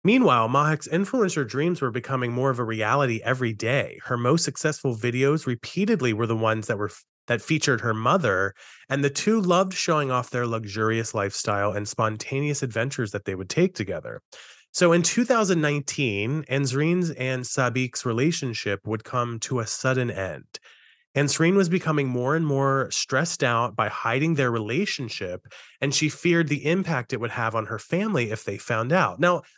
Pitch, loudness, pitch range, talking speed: 135 Hz, -24 LUFS, 115-155 Hz, 170 wpm